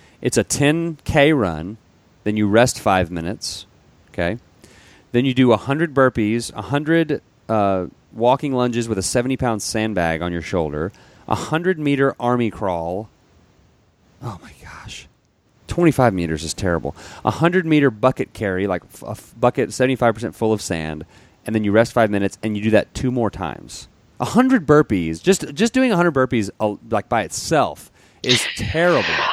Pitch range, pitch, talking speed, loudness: 95-130 Hz, 110 Hz, 155 wpm, -19 LUFS